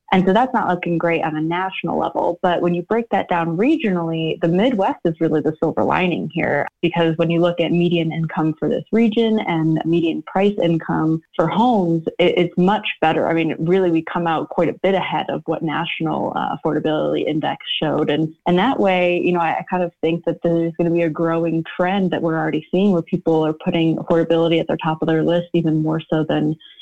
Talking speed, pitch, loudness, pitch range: 215 wpm, 170 Hz, -19 LUFS, 160-180 Hz